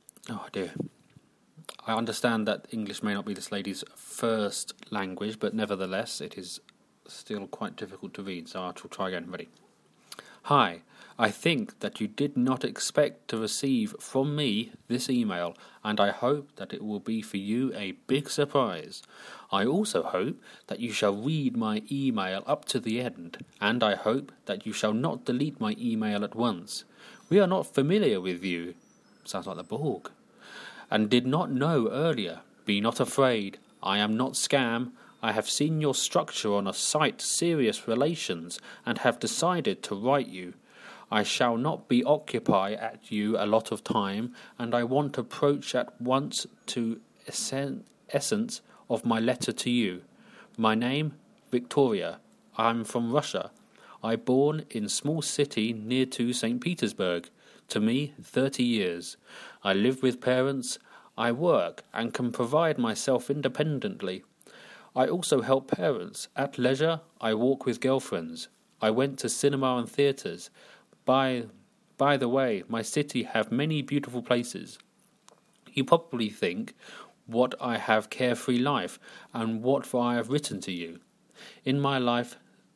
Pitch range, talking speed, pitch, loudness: 110-140 Hz, 155 wpm, 125 Hz, -29 LUFS